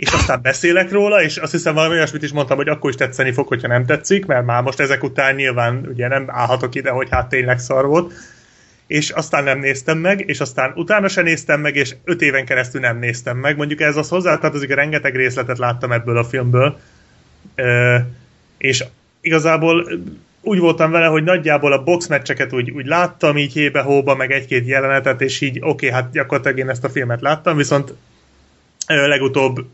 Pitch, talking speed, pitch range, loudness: 140 Hz, 195 wpm, 130-155 Hz, -16 LUFS